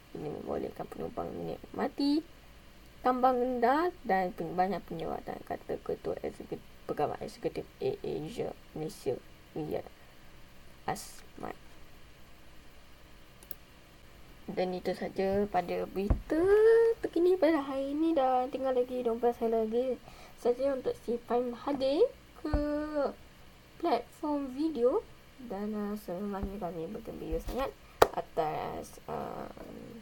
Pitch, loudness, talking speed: 240 Hz, -32 LUFS, 100 wpm